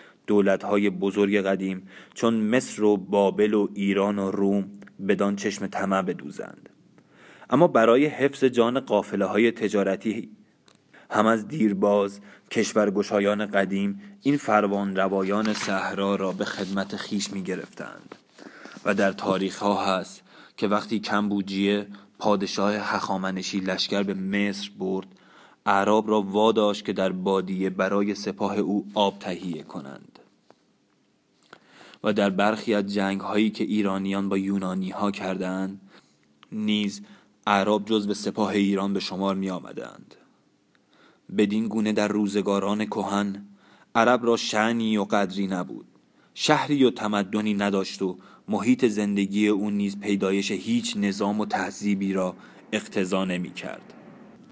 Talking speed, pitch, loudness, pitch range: 125 wpm, 100 Hz, -25 LUFS, 95-105 Hz